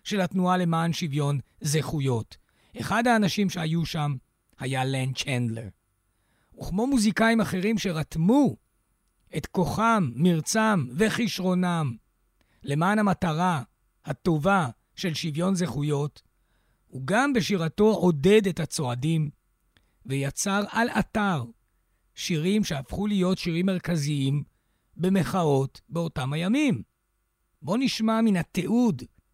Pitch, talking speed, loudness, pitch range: 165 Hz, 95 wpm, -25 LUFS, 135-195 Hz